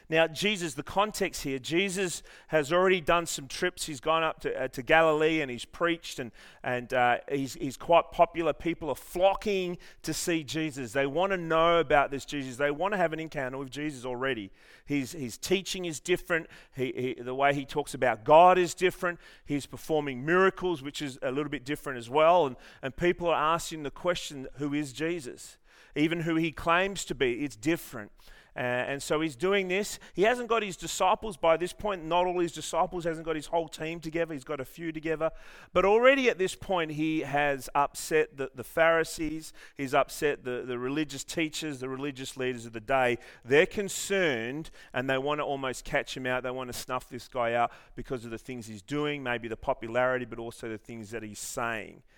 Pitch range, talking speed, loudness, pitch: 130-170 Hz, 205 wpm, -29 LUFS, 155 Hz